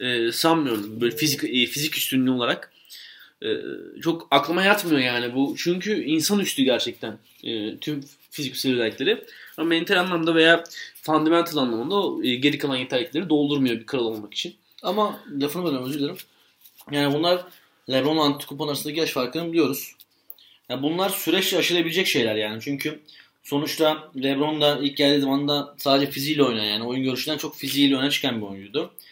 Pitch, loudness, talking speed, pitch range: 145 Hz, -23 LUFS, 145 wpm, 130-165 Hz